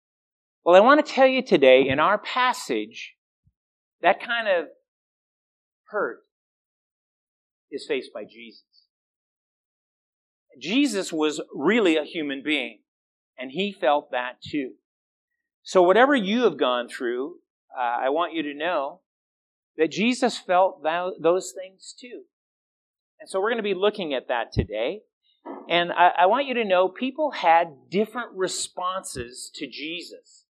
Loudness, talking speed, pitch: -23 LUFS, 135 wpm, 185 Hz